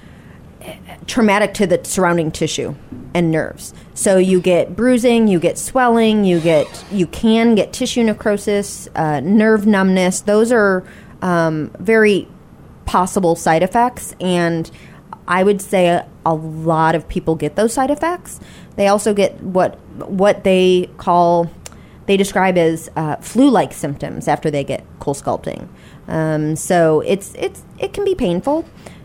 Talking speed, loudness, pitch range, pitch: 145 wpm, -16 LUFS, 165-215 Hz, 185 Hz